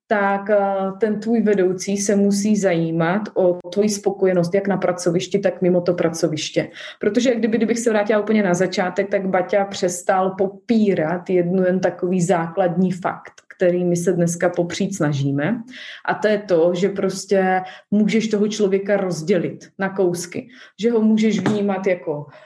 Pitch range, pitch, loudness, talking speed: 180-210 Hz, 195 Hz, -20 LUFS, 155 wpm